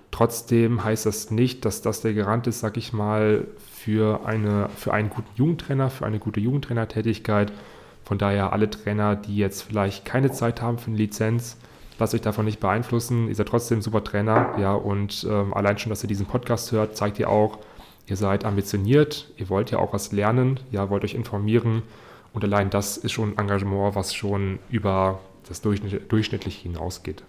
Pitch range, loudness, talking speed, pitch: 100-115 Hz, -24 LUFS, 190 wpm, 110 Hz